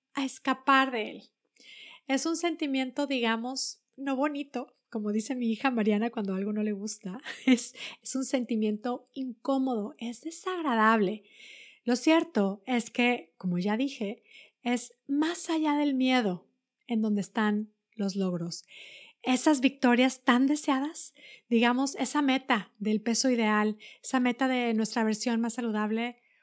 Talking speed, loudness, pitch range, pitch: 140 wpm, -29 LUFS, 220-270 Hz, 245 Hz